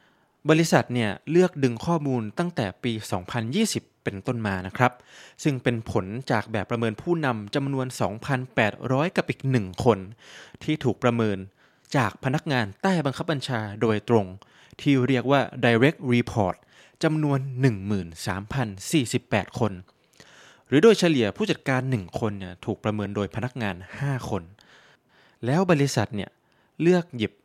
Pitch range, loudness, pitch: 105-140 Hz, -25 LUFS, 125 Hz